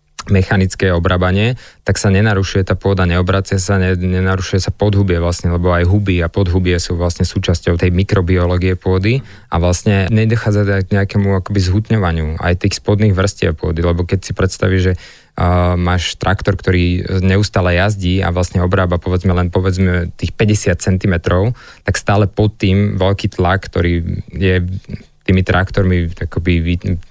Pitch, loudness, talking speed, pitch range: 95 Hz, -15 LUFS, 150 wpm, 90-100 Hz